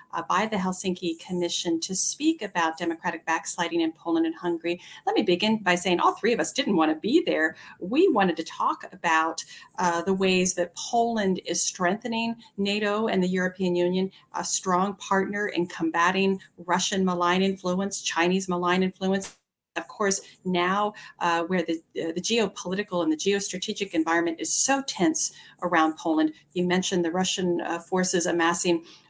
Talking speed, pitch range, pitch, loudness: 165 wpm, 170-195 Hz, 180 Hz, -25 LUFS